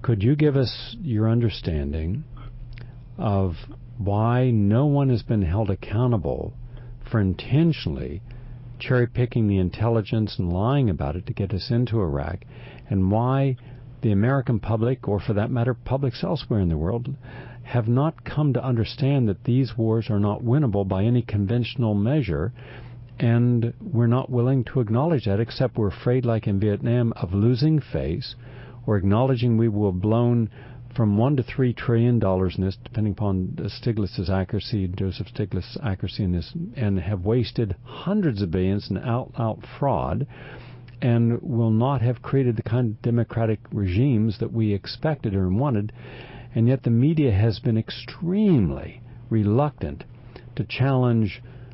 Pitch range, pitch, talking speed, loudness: 105-125 Hz, 120 Hz, 155 wpm, -23 LUFS